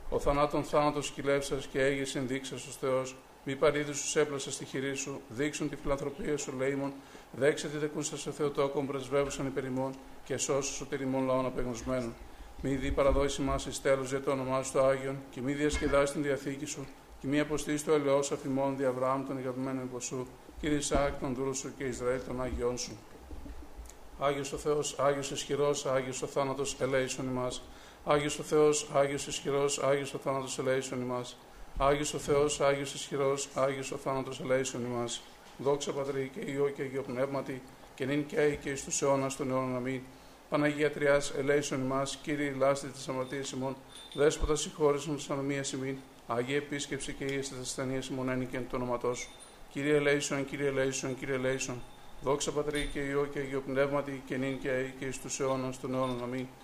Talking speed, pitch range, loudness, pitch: 180 wpm, 130-145 Hz, -32 LUFS, 140 Hz